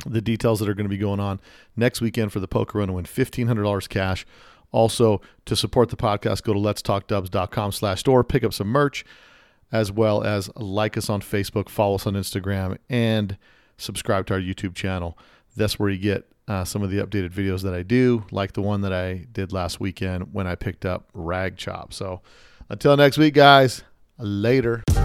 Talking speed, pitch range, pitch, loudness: 200 wpm, 95-115 Hz, 105 Hz, -23 LUFS